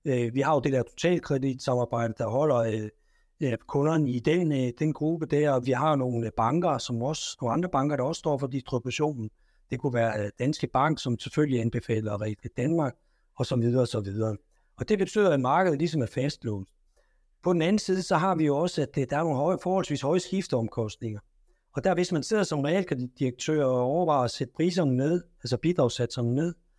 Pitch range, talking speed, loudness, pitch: 120-165 Hz, 195 wpm, -27 LUFS, 140 Hz